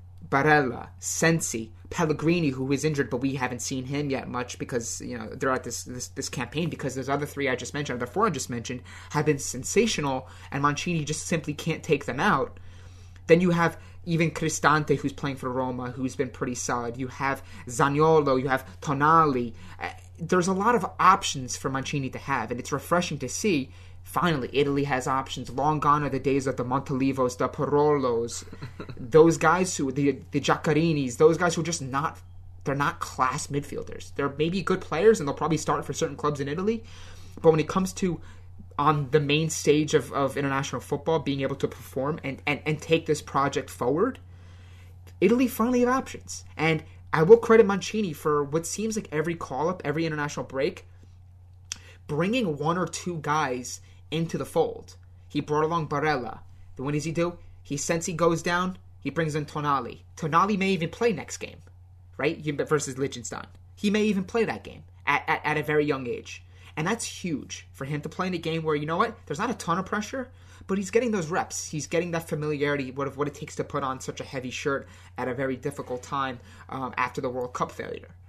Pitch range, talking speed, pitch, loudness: 120-160 Hz, 200 wpm, 140 Hz, -26 LUFS